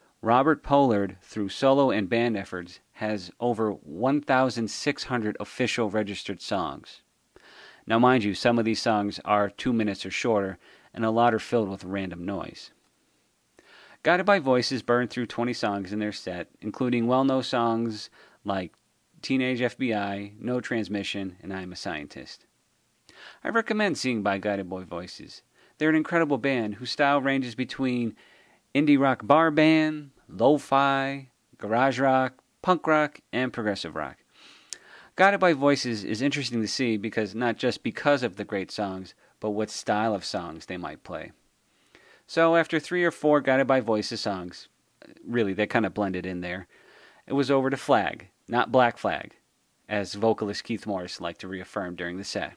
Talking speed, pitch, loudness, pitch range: 160 wpm, 115 Hz, -26 LUFS, 100-135 Hz